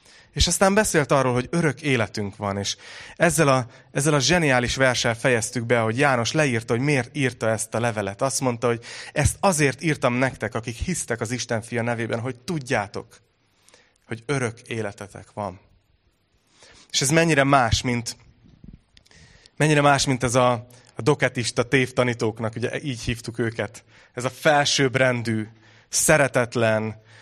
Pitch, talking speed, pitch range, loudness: 125 Hz, 145 wpm, 115-135 Hz, -22 LUFS